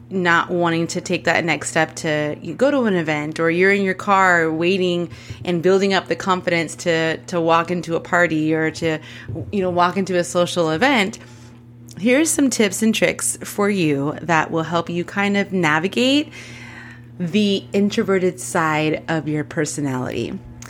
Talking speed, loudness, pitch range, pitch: 170 wpm, -19 LUFS, 155-190 Hz, 170 Hz